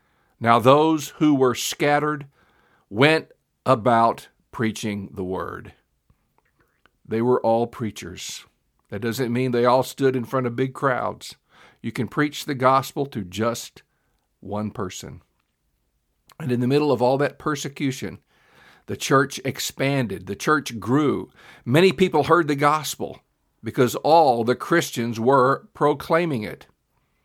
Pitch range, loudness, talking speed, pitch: 115-145 Hz, -22 LUFS, 130 wpm, 130 Hz